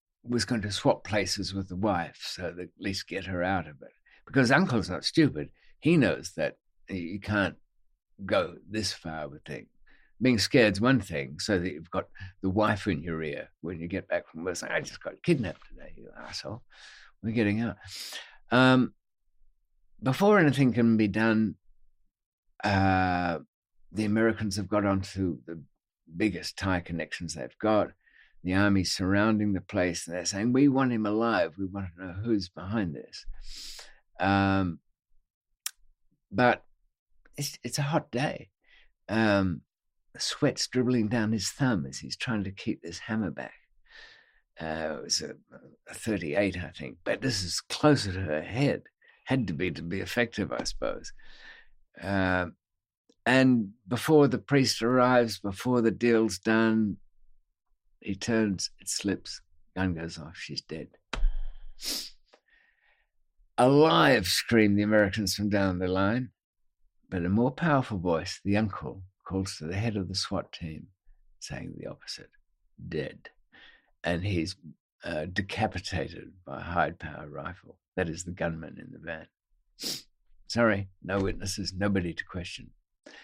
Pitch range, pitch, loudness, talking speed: 90-115 Hz, 100 Hz, -28 LUFS, 150 wpm